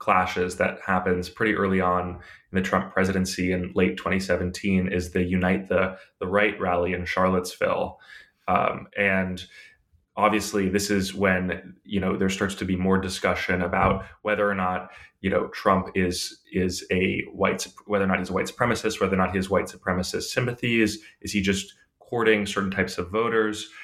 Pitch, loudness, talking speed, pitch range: 95 Hz, -25 LUFS, 180 wpm, 90-100 Hz